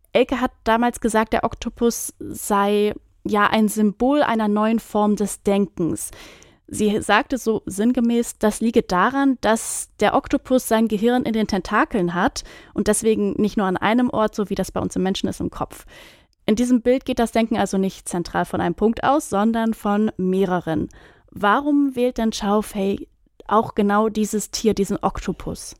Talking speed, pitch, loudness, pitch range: 175 wpm, 215 Hz, -21 LUFS, 205-235 Hz